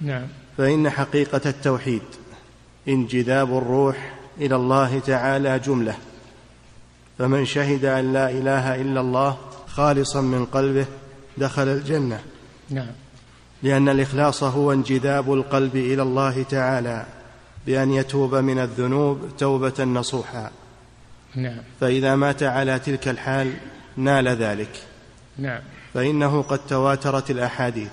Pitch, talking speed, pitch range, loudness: 135 Hz, 100 wpm, 130-135 Hz, -22 LUFS